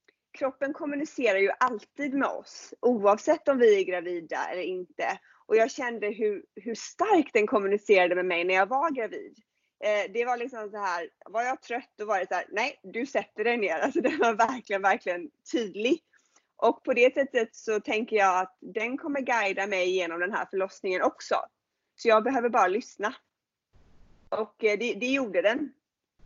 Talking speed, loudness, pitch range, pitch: 185 wpm, -27 LUFS, 200-275 Hz, 230 Hz